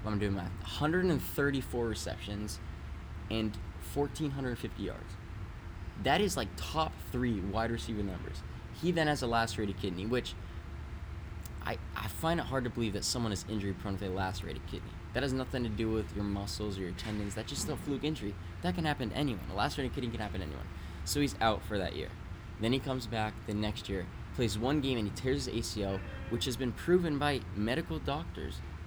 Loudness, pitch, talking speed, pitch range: -35 LUFS, 105 Hz, 195 wpm, 90-120 Hz